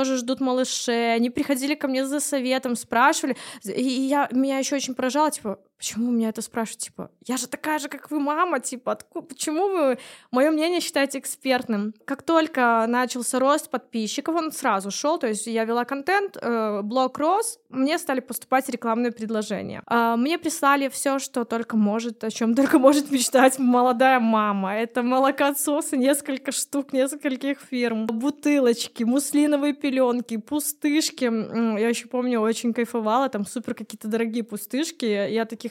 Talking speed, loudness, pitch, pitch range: 160 wpm, -23 LUFS, 260 Hz, 235-285 Hz